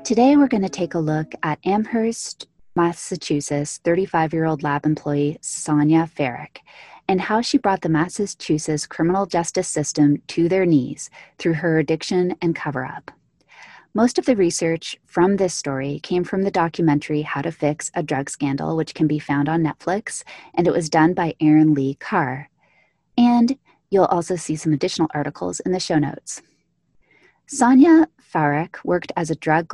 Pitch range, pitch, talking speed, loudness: 150-190 Hz, 165 Hz, 160 wpm, -20 LUFS